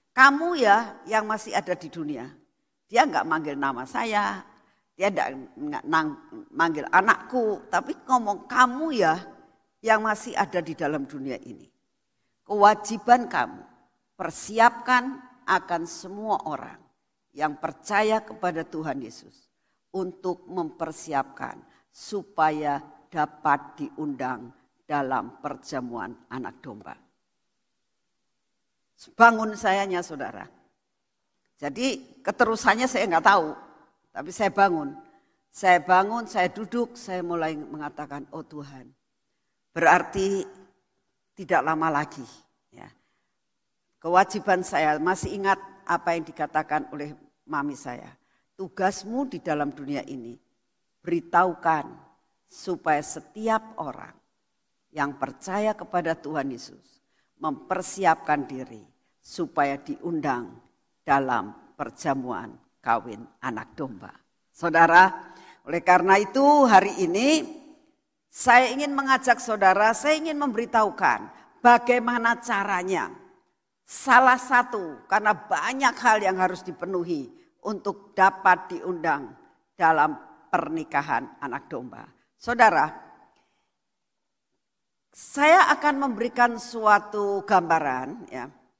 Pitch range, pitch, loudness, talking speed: 160-240 Hz, 190 Hz, -24 LUFS, 95 wpm